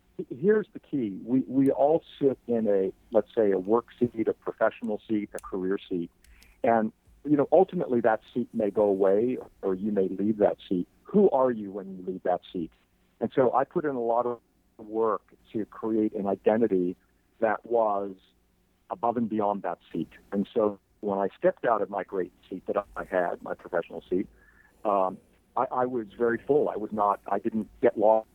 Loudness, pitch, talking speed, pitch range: -28 LUFS, 110 Hz, 195 wpm, 100-120 Hz